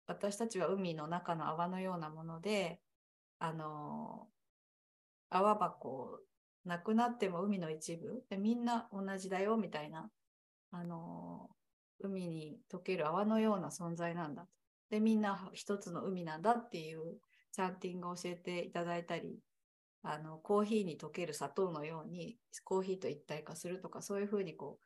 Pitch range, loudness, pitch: 160-205 Hz, -40 LUFS, 180 Hz